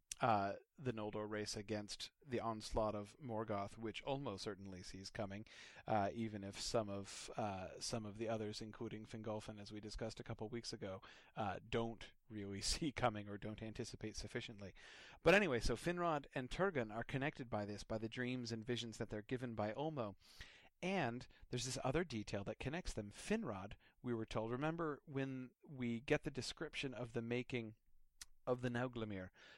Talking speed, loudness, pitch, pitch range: 175 wpm, -44 LUFS, 115 Hz, 105-125 Hz